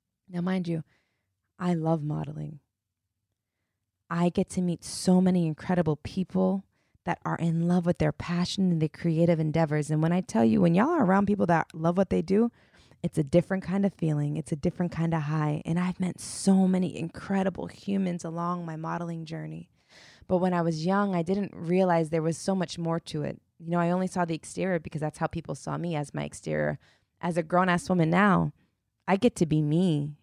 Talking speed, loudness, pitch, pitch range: 210 wpm, -27 LUFS, 170 Hz, 155-185 Hz